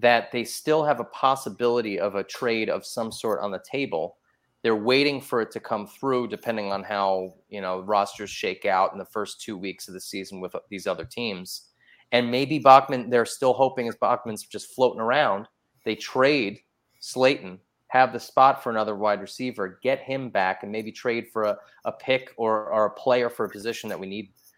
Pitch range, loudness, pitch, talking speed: 100-130 Hz, -25 LUFS, 115 Hz, 205 wpm